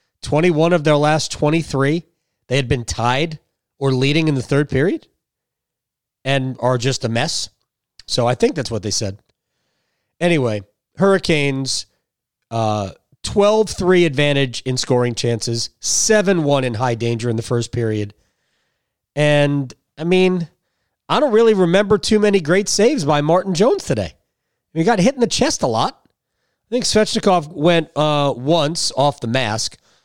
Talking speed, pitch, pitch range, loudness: 160 wpm, 145 Hz, 120-175 Hz, -17 LUFS